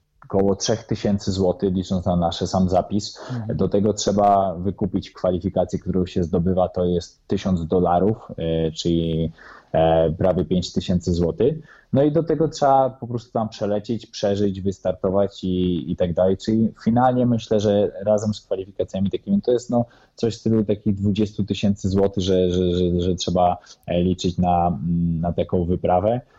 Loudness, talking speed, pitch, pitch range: -21 LUFS, 150 wpm, 95 Hz, 90-110 Hz